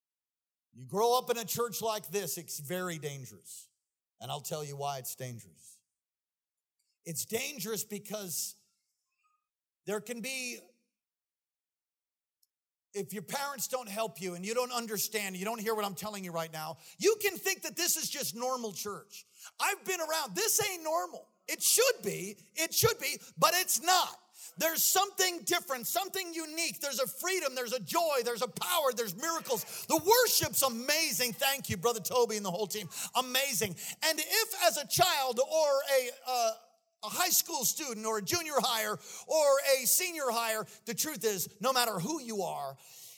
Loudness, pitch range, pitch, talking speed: -31 LUFS, 205-320 Hz, 245 Hz, 170 wpm